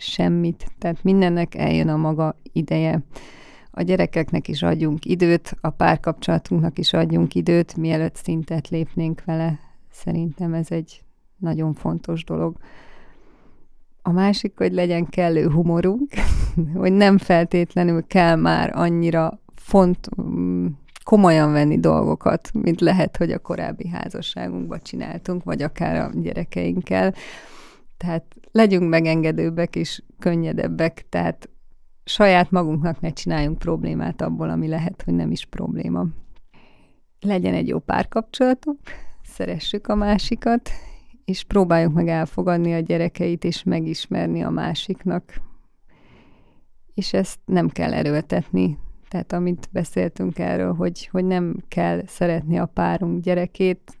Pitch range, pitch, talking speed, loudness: 145-180 Hz, 165 Hz, 120 wpm, -21 LUFS